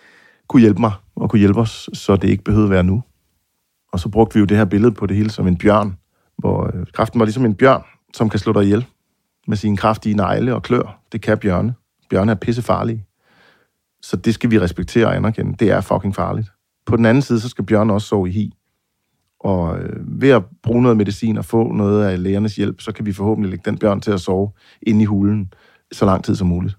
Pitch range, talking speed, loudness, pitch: 100-115 Hz, 230 wpm, -17 LUFS, 105 Hz